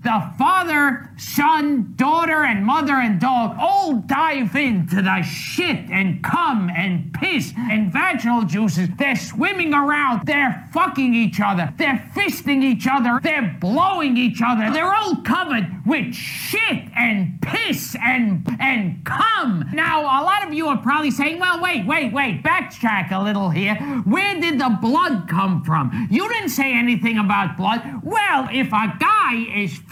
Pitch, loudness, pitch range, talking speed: 240 Hz, -19 LUFS, 205-290 Hz, 155 wpm